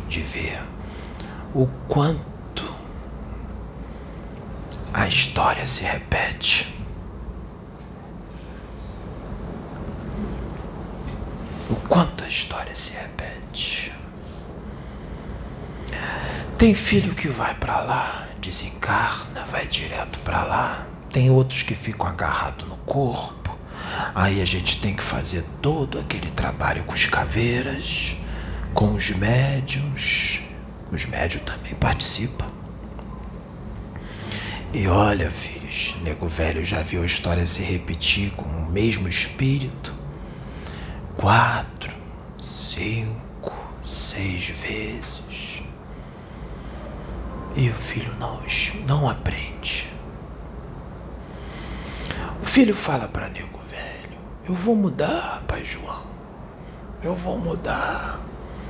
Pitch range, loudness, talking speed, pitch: 75-110 Hz, -22 LUFS, 90 wpm, 90 Hz